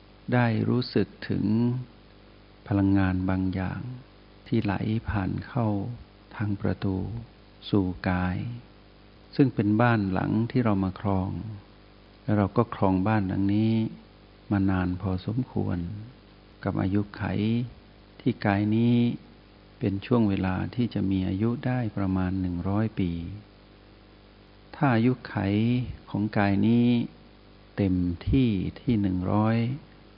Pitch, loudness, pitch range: 105 Hz, -27 LUFS, 95-110 Hz